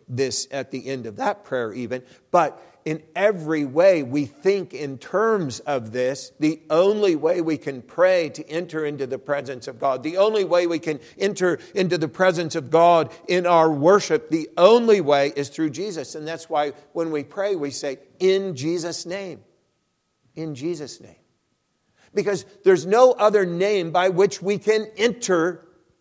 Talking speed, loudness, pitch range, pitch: 175 wpm, -21 LUFS, 145-190 Hz, 165 Hz